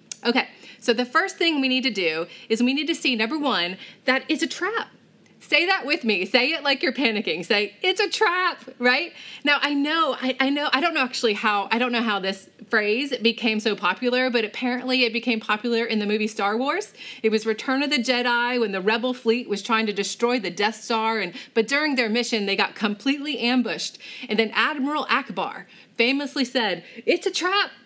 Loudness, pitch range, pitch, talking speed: -23 LUFS, 220-280 Hz, 245 Hz, 215 wpm